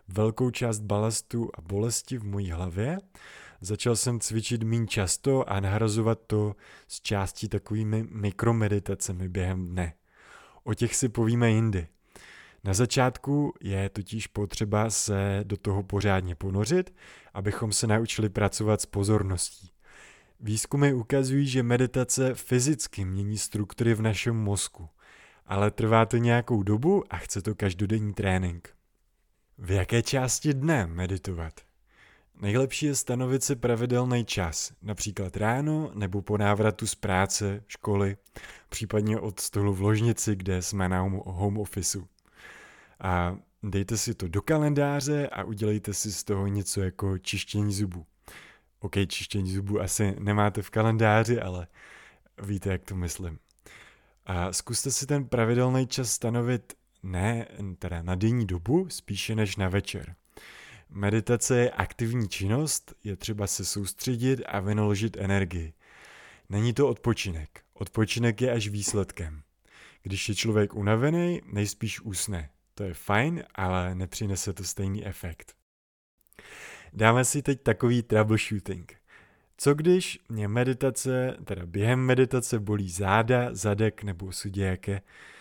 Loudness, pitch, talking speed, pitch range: -28 LUFS, 105 Hz, 130 wpm, 95-115 Hz